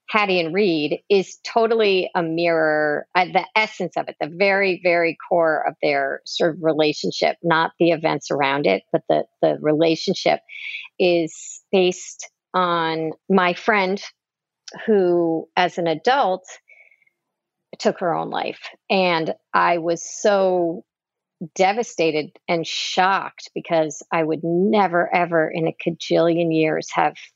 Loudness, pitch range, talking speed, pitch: -20 LUFS, 165-195 Hz, 130 wpm, 175 Hz